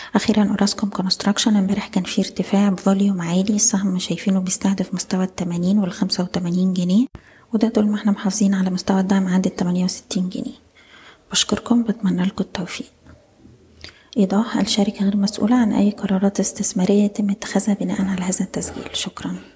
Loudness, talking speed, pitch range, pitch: -19 LUFS, 150 wpm, 190-210 Hz, 200 Hz